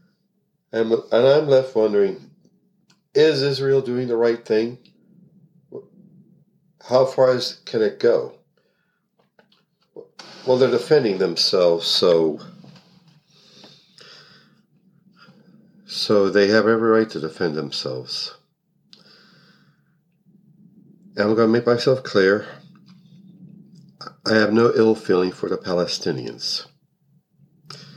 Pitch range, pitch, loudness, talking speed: 125-195 Hz, 175 Hz, -19 LUFS, 95 wpm